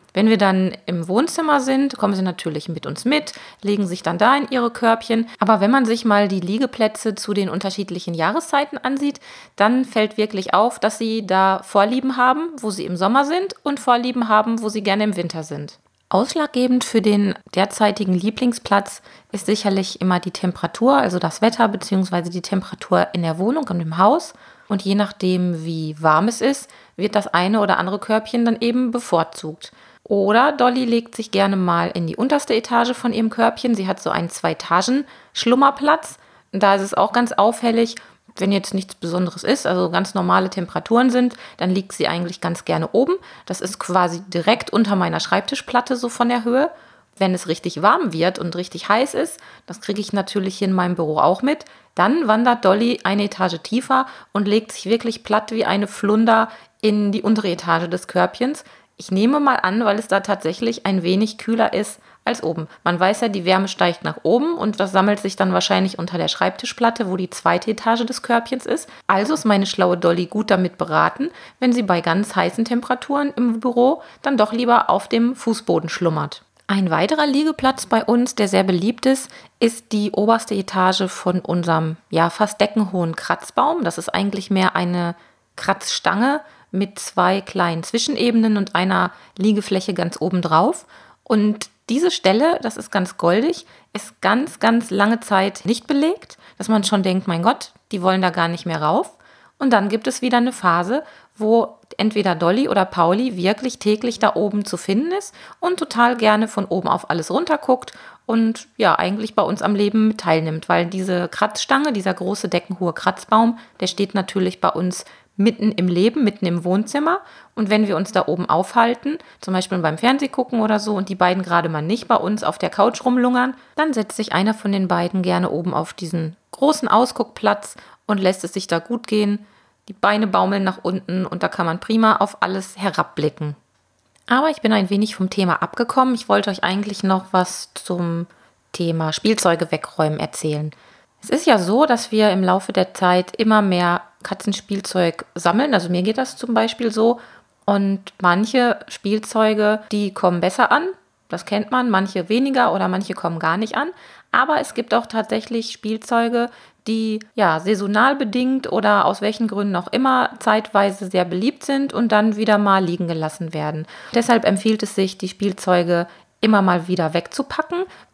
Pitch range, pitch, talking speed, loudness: 185-235 Hz, 205 Hz, 185 wpm, -19 LUFS